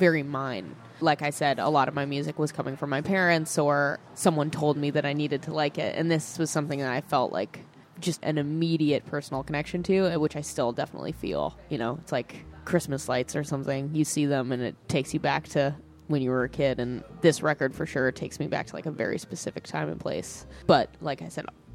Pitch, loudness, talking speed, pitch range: 145 Hz, -28 LUFS, 235 wpm, 135-155 Hz